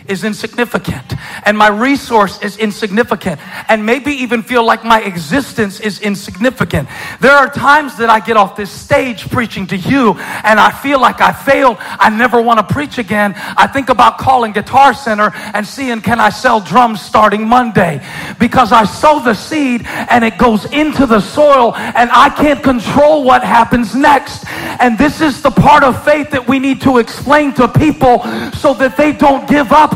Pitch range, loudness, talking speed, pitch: 215-275 Hz, -10 LUFS, 185 wpm, 240 Hz